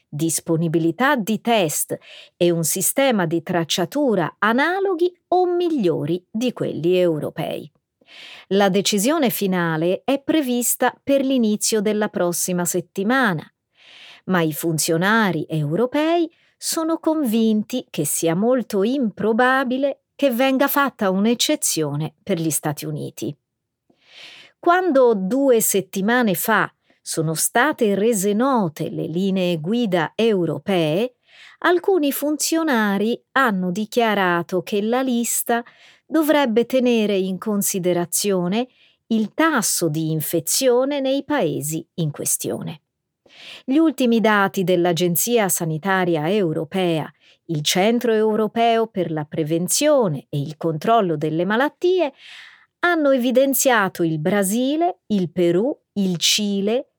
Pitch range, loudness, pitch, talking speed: 175-255 Hz, -20 LUFS, 210 Hz, 105 wpm